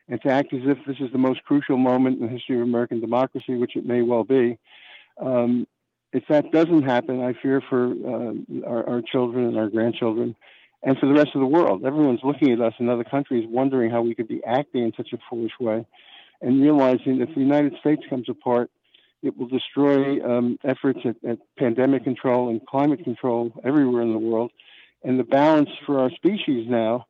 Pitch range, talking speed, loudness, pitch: 120-135 Hz, 210 wpm, -22 LUFS, 125 Hz